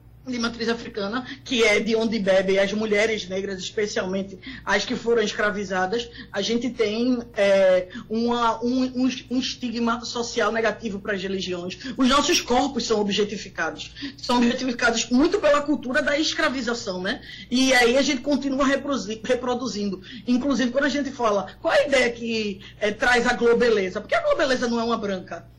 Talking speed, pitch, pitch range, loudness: 165 wpm, 235 Hz, 210-255 Hz, -23 LUFS